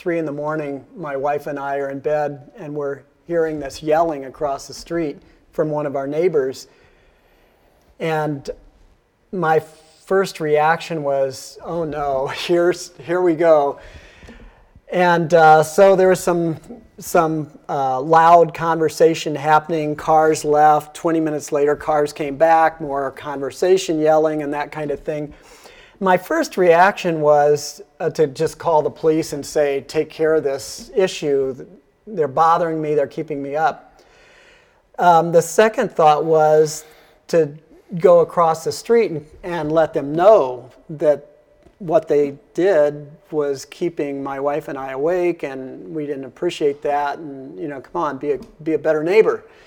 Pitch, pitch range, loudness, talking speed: 155 Hz, 145-170 Hz, -18 LUFS, 155 wpm